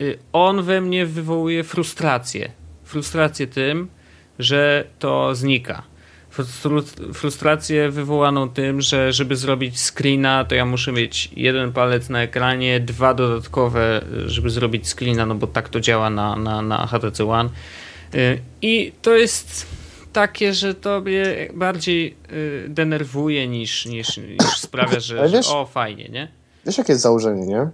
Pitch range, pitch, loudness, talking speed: 115-150 Hz, 130 Hz, -19 LUFS, 135 wpm